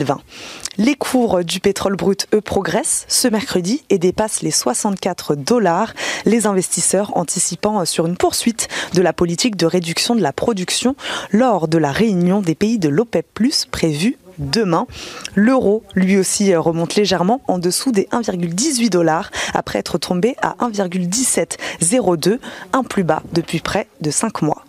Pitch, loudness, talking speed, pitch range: 195 Hz, -17 LUFS, 150 wpm, 175-230 Hz